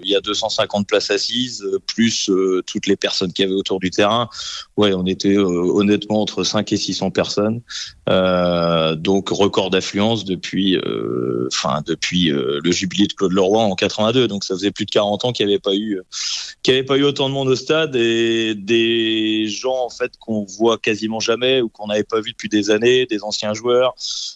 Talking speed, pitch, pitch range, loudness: 205 wpm, 105 Hz, 95-115 Hz, -18 LUFS